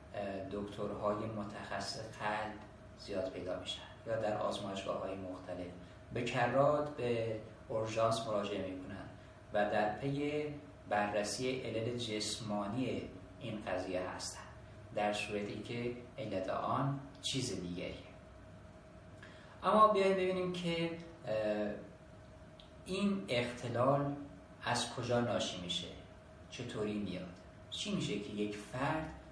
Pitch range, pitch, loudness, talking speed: 95-125 Hz, 105 Hz, -37 LUFS, 100 wpm